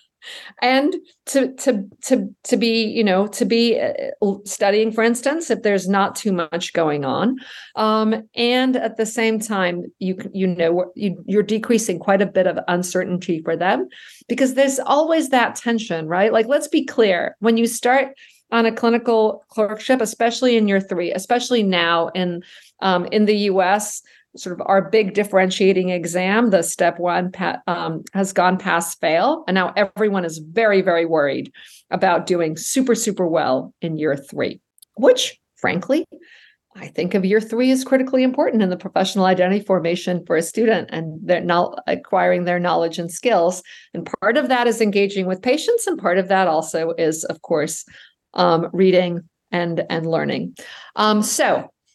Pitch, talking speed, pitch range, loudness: 205 Hz, 165 wpm, 180-235 Hz, -19 LUFS